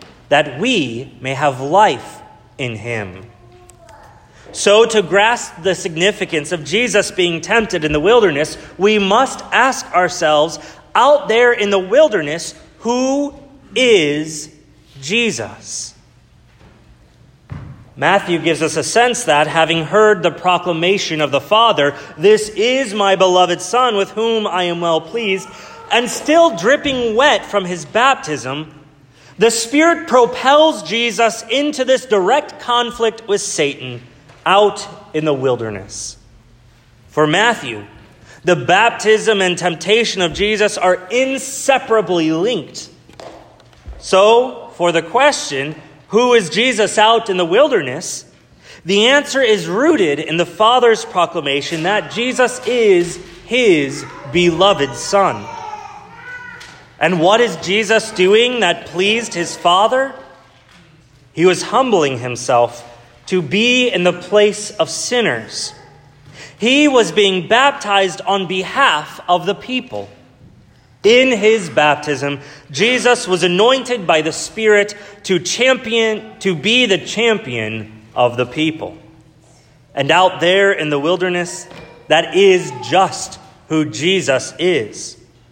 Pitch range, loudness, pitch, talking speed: 150-230 Hz, -14 LUFS, 185 Hz, 120 wpm